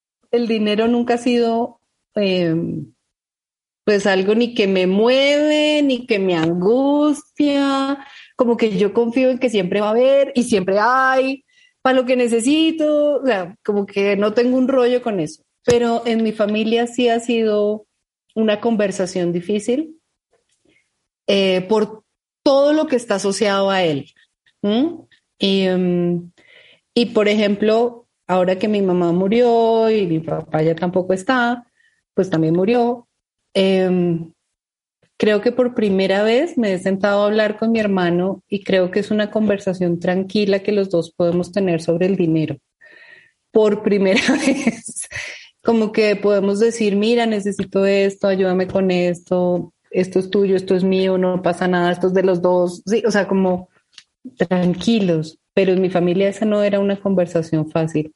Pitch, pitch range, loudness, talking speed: 210 Hz, 185-240 Hz, -18 LUFS, 160 wpm